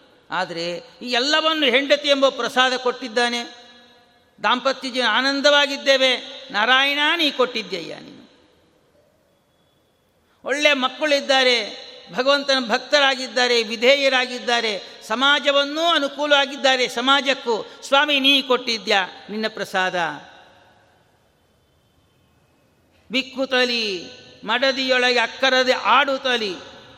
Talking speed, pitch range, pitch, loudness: 70 wpm, 240-275 Hz, 255 Hz, -19 LUFS